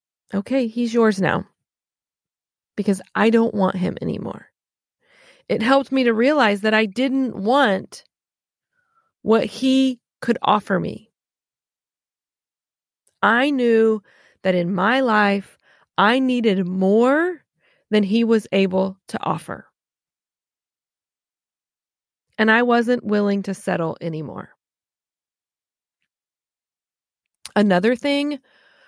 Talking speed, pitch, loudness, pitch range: 100 wpm, 225 Hz, -19 LUFS, 200-265 Hz